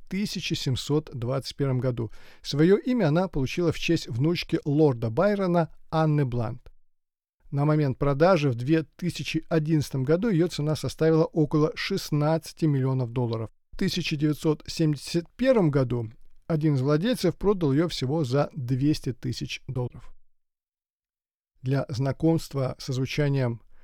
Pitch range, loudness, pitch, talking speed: 130-165 Hz, -26 LUFS, 150 Hz, 110 wpm